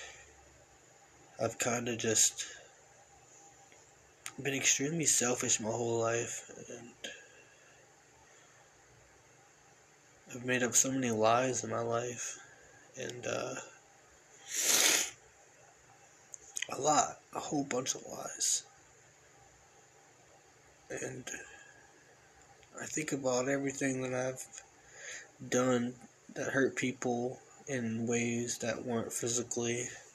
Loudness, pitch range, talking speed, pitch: -33 LUFS, 120-130 Hz, 90 wpm, 125 Hz